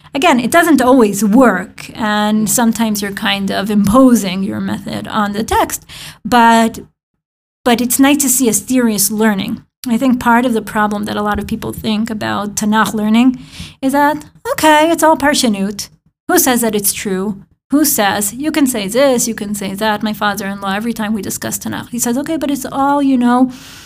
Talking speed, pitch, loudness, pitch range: 190 wpm, 230 Hz, -13 LUFS, 210-260 Hz